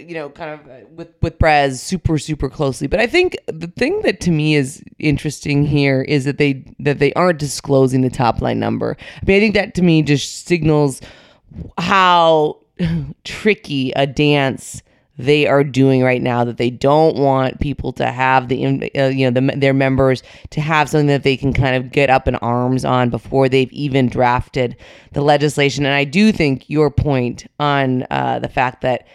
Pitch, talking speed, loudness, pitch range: 140 Hz, 195 wpm, -16 LUFS, 130-150 Hz